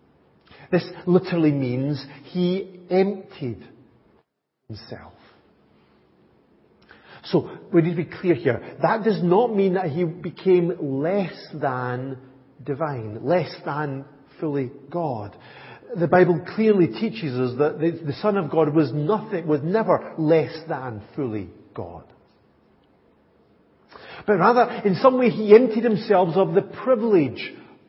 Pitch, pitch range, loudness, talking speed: 165 Hz, 140-190 Hz, -22 LUFS, 125 wpm